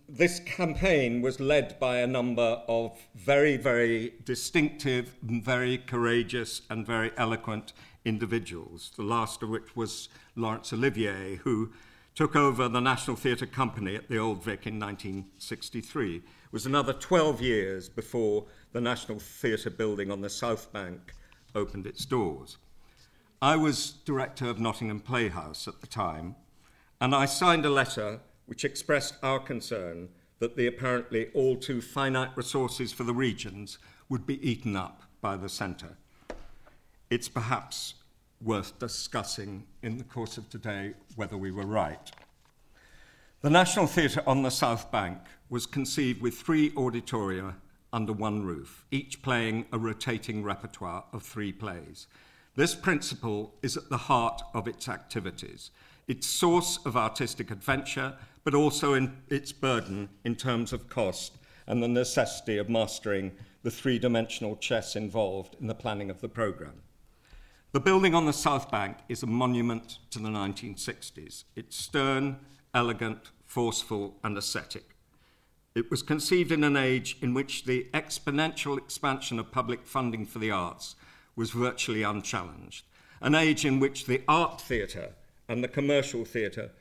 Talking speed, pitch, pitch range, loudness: 145 wpm, 120 Hz, 110-135 Hz, -30 LUFS